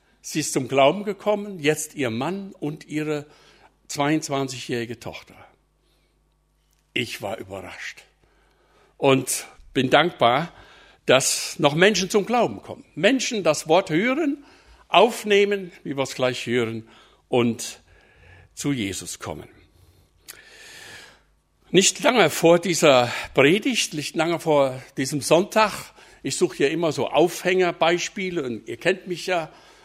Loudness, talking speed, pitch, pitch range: -22 LUFS, 120 wpm, 165 Hz, 140-205 Hz